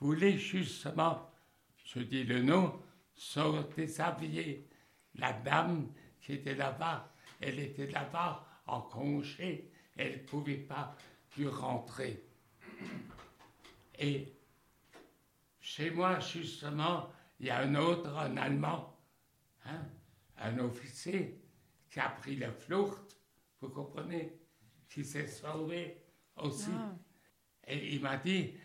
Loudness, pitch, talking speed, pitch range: -38 LUFS, 150 Hz, 110 wpm, 135-170 Hz